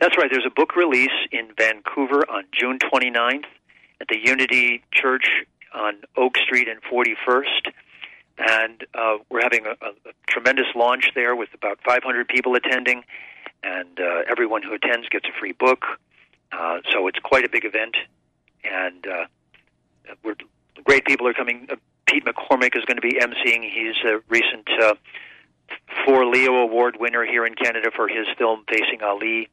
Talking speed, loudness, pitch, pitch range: 165 wpm, -20 LUFS, 120 Hz, 110-125 Hz